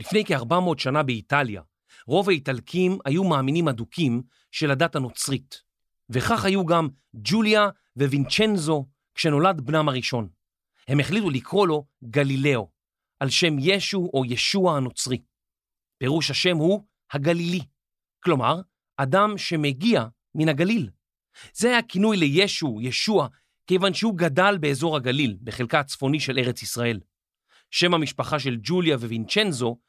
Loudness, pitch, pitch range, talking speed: -23 LUFS, 145 Hz, 125-180 Hz, 120 wpm